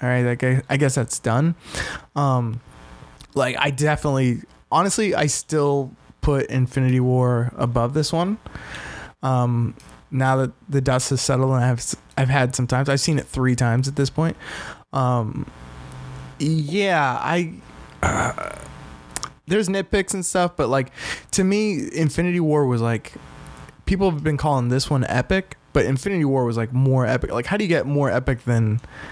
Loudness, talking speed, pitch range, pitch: -21 LUFS, 165 wpm, 125-150 Hz, 135 Hz